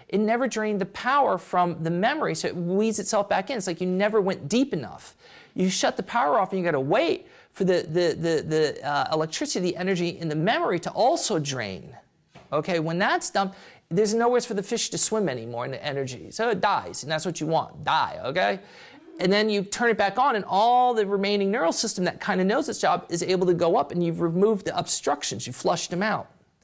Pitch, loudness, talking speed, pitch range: 190 Hz, -25 LUFS, 230 wpm, 170-220 Hz